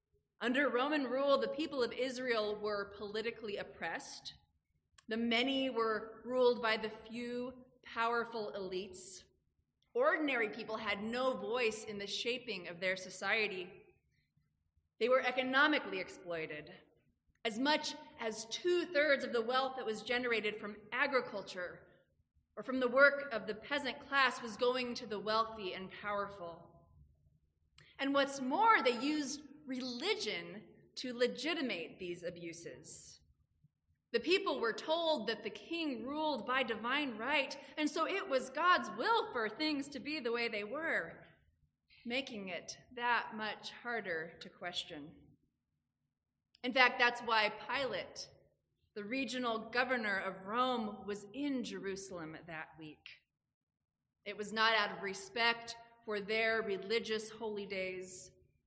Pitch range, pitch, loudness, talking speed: 205-265 Hz, 230 Hz, -36 LUFS, 135 wpm